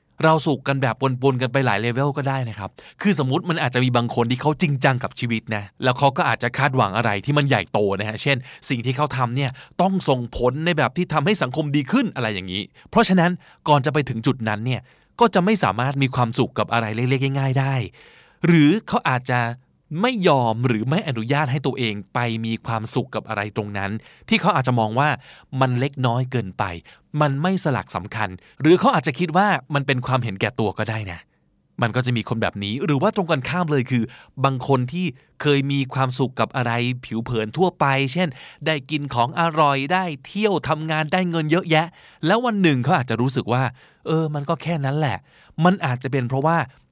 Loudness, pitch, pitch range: -21 LUFS, 135 Hz, 120-155 Hz